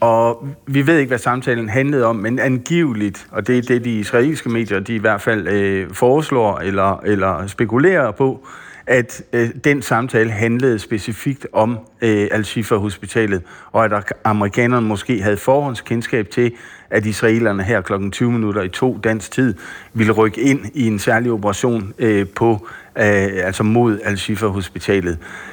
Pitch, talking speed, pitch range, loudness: 115 Hz, 155 wpm, 105-120 Hz, -17 LUFS